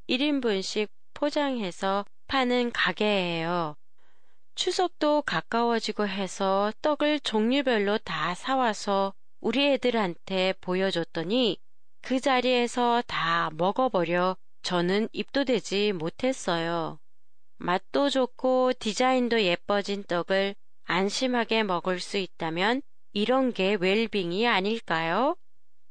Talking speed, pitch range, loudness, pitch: 225 characters per minute, 185-255 Hz, -27 LUFS, 210 Hz